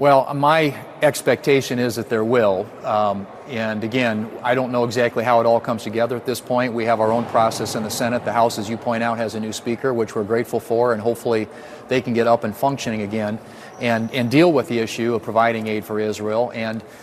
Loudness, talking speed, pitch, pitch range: -20 LUFS, 230 wpm, 115 Hz, 110-125 Hz